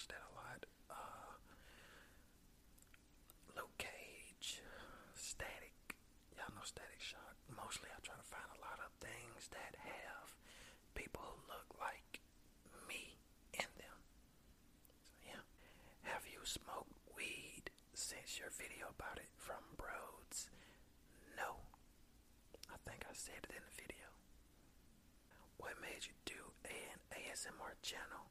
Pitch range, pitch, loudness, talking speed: 60-80 Hz, 75 Hz, -53 LUFS, 125 wpm